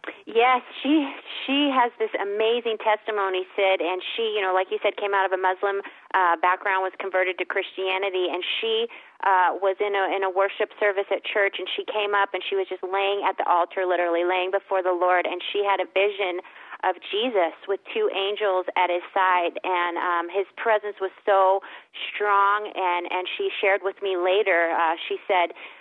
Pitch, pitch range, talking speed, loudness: 195 Hz, 185-210 Hz, 200 wpm, -24 LUFS